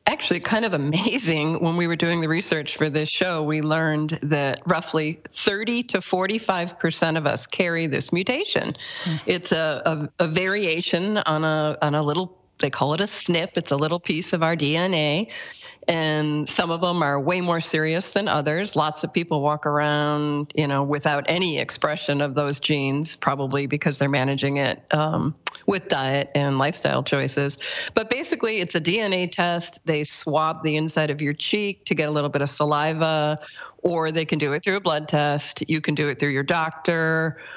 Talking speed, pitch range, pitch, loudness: 185 wpm, 150-180 Hz, 160 Hz, -23 LUFS